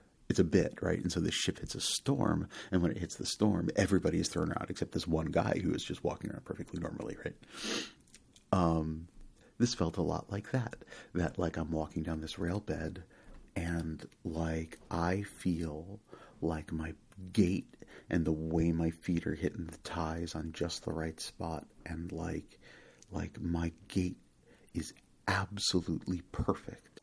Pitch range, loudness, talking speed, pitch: 80-90 Hz, -35 LUFS, 170 wpm, 85 Hz